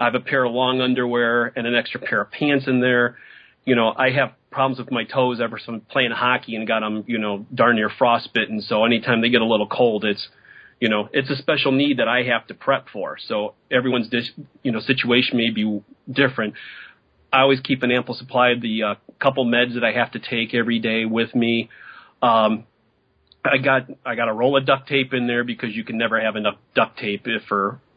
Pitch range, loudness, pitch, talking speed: 115-130 Hz, -20 LUFS, 120 Hz, 230 wpm